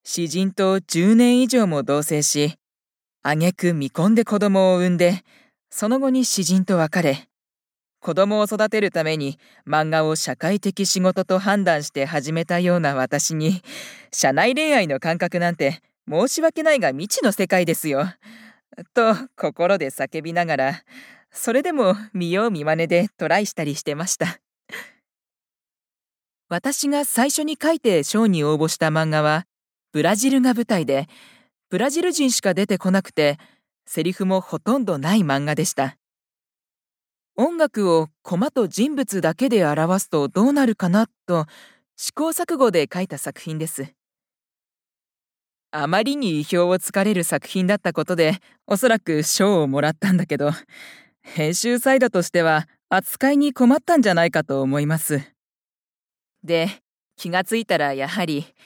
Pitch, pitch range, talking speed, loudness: 185 Hz, 160-225 Hz, 280 characters per minute, -20 LUFS